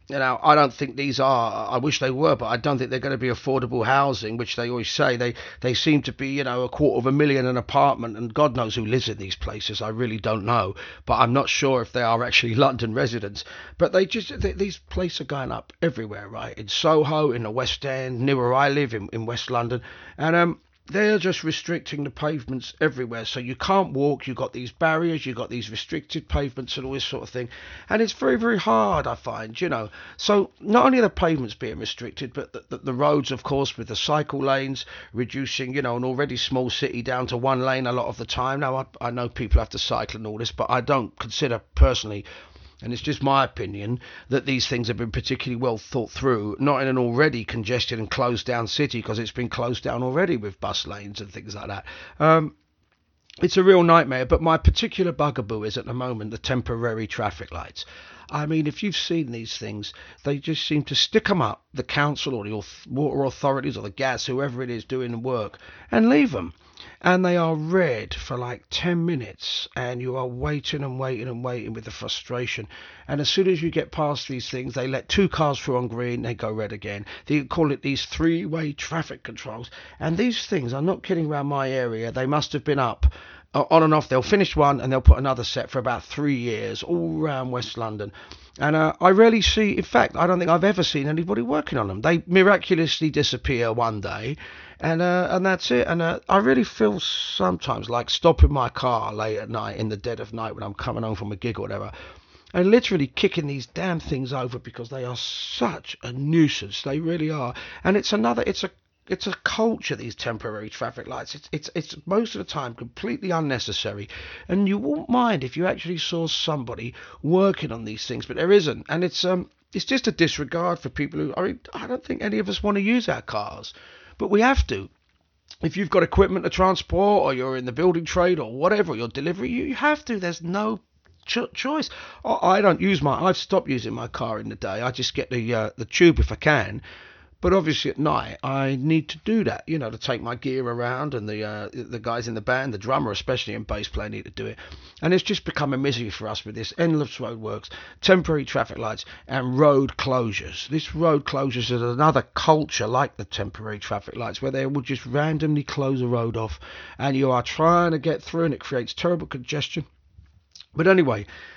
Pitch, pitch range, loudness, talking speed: 135 Hz, 120-160 Hz, -23 LUFS, 225 wpm